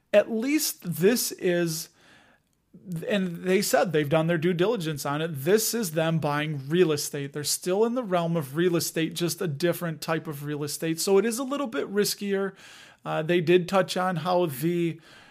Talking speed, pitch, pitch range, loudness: 190 wpm, 175 Hz, 160-195 Hz, -26 LUFS